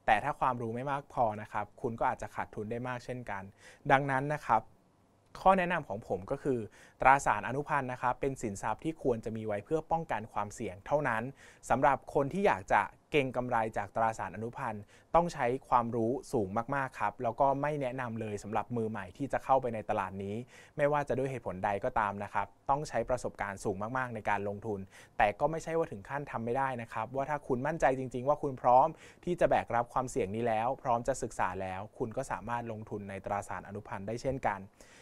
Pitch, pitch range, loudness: 120 Hz, 105-135 Hz, -33 LUFS